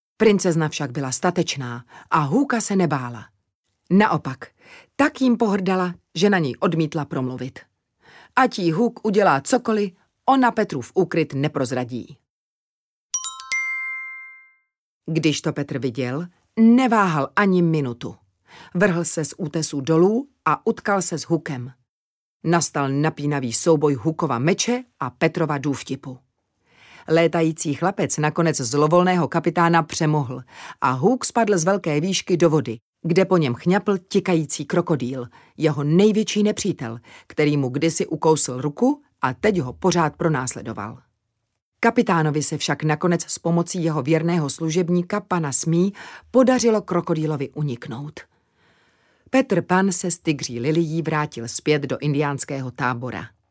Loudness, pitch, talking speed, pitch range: -21 LUFS, 165 Hz, 125 wpm, 140-190 Hz